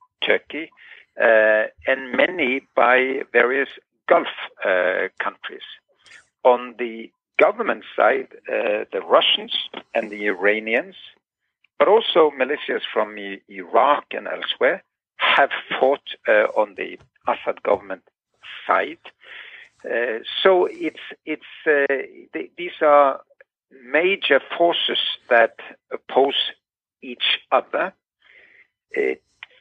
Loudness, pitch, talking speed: -20 LUFS, 145 Hz, 100 wpm